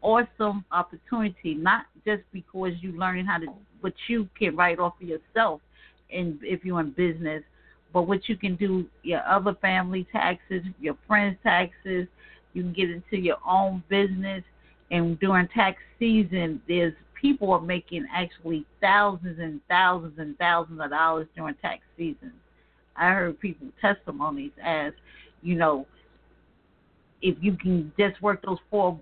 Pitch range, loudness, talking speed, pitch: 170-200 Hz, -26 LUFS, 155 wpm, 185 Hz